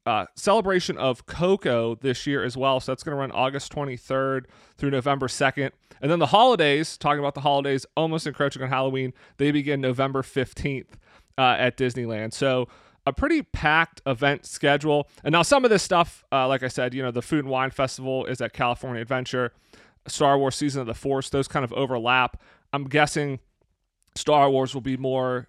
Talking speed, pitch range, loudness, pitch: 190 wpm, 130-145 Hz, -24 LUFS, 135 Hz